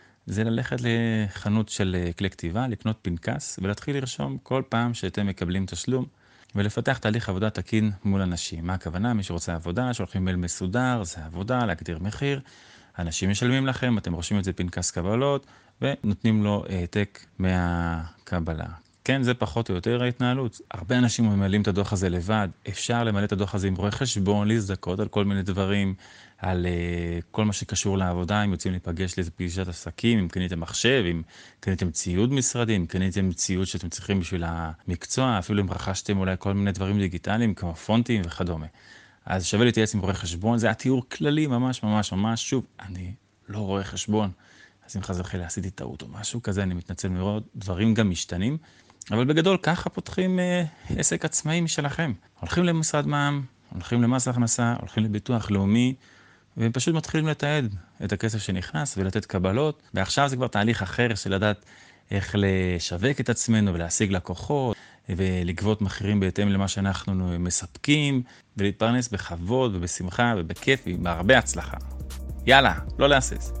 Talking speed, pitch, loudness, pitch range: 150 wpm, 100 Hz, -26 LUFS, 90-120 Hz